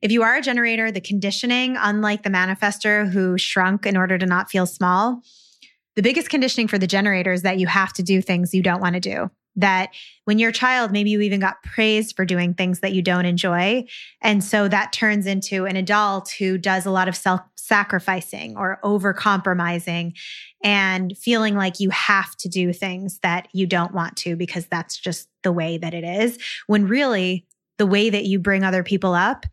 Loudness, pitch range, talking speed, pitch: -20 LUFS, 185-210 Hz, 205 wpm, 195 Hz